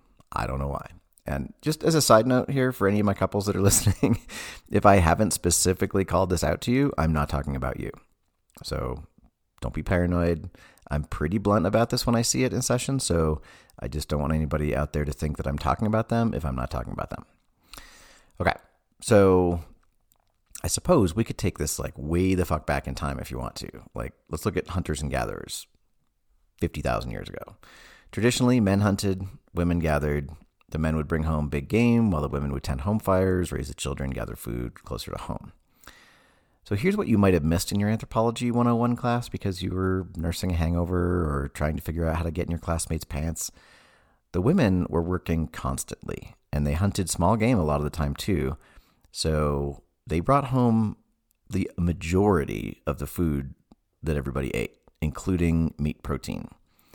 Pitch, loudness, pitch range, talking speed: 85 Hz, -26 LUFS, 75-100 Hz, 195 wpm